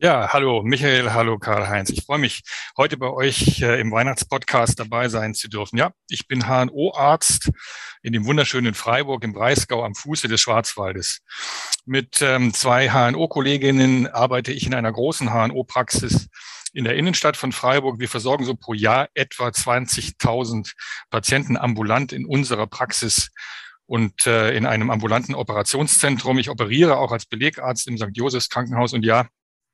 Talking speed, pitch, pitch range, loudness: 155 wpm, 125 Hz, 115-135 Hz, -20 LUFS